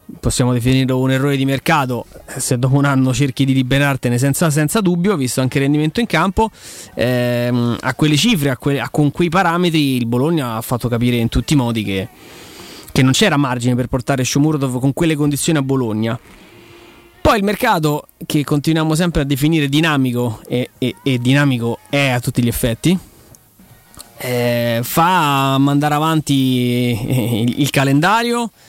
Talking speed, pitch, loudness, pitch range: 165 wpm, 135 Hz, -16 LUFS, 125-155 Hz